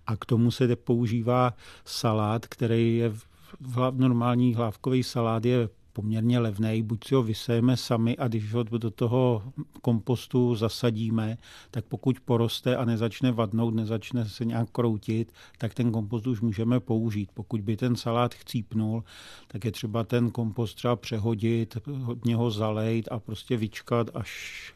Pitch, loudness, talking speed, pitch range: 115 Hz, -28 LUFS, 155 wpm, 110-120 Hz